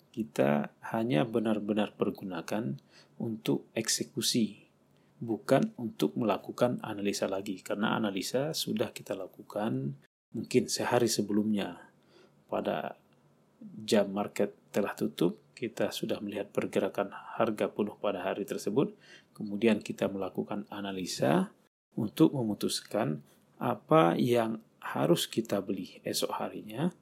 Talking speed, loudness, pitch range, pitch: 100 wpm, -32 LUFS, 100-115 Hz, 105 Hz